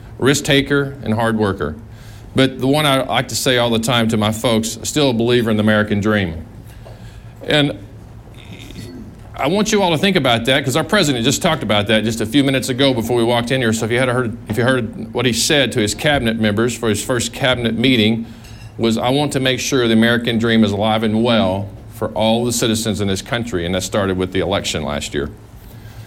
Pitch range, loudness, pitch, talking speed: 110-130 Hz, -16 LUFS, 115 Hz, 225 wpm